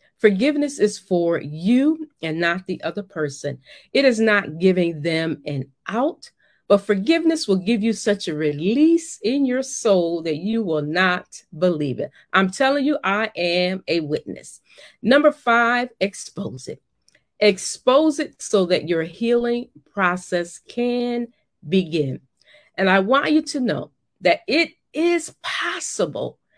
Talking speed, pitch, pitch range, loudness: 140 wpm, 200 Hz, 170-255 Hz, -21 LUFS